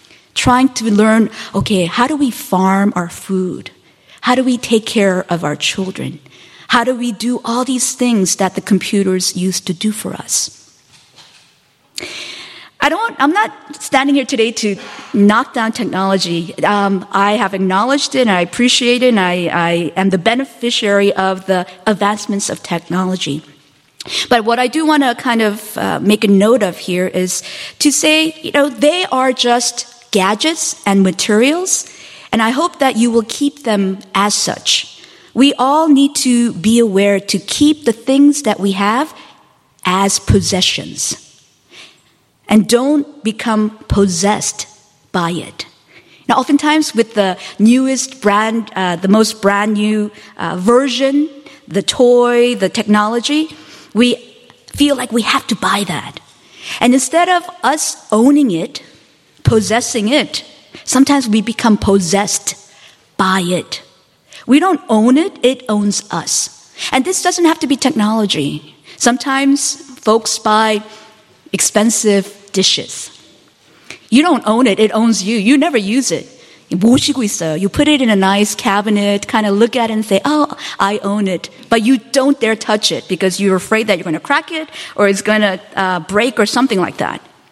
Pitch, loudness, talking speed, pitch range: 220 Hz, -14 LUFS, 160 wpm, 200-265 Hz